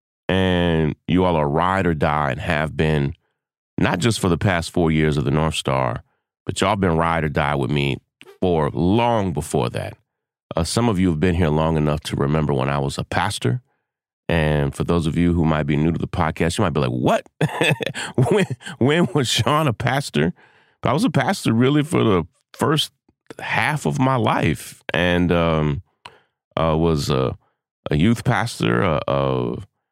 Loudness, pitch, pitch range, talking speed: -20 LUFS, 85 Hz, 75-95 Hz, 190 wpm